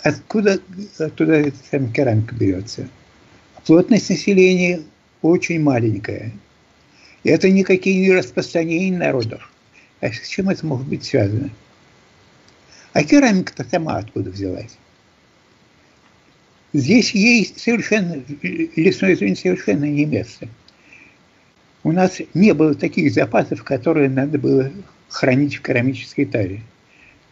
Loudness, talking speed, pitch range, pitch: -18 LUFS, 105 wpm, 120-185 Hz, 150 Hz